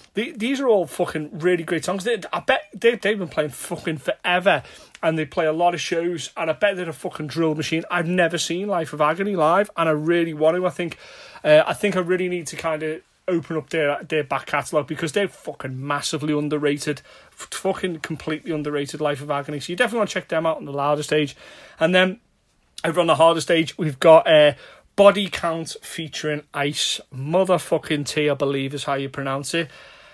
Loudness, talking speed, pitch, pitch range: -22 LUFS, 210 wpm, 165 Hz, 150-180 Hz